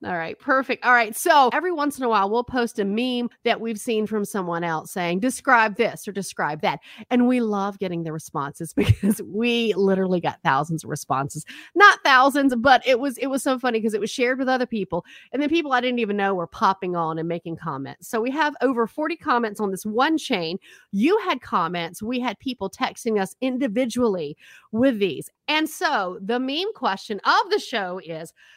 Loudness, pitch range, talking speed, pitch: -22 LUFS, 190-260 Hz, 210 wpm, 230 Hz